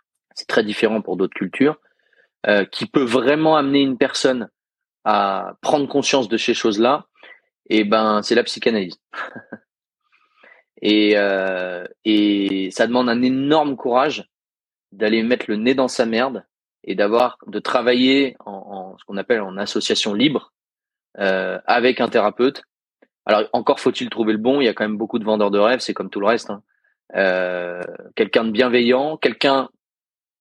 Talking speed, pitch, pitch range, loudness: 160 wpm, 120 Hz, 105-135 Hz, -19 LUFS